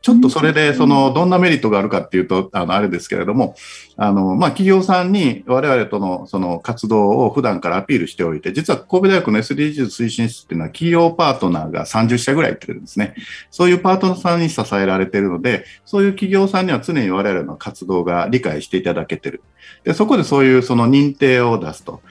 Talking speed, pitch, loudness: 460 characters per minute, 125 Hz, -16 LUFS